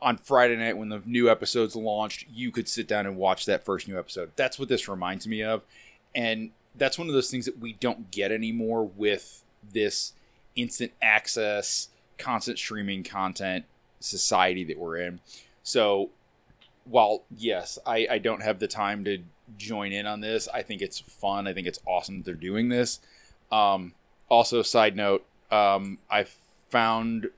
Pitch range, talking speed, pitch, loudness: 100-115 Hz, 175 wpm, 110 Hz, -27 LUFS